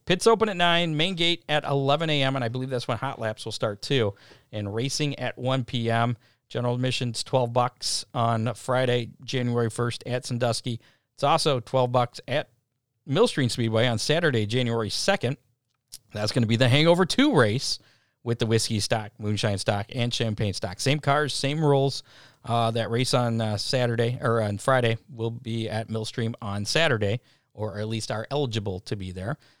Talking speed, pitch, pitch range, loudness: 180 wpm, 120 Hz, 115-135 Hz, -25 LUFS